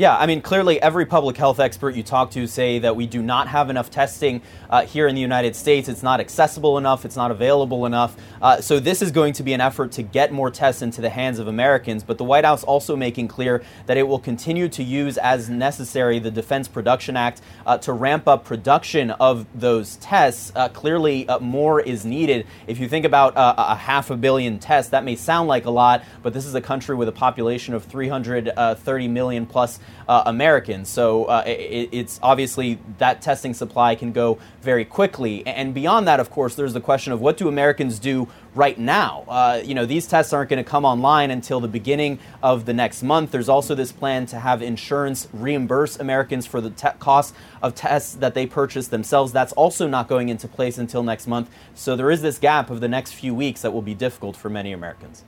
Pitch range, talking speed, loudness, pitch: 120-140 Hz, 220 wpm, -20 LUFS, 125 Hz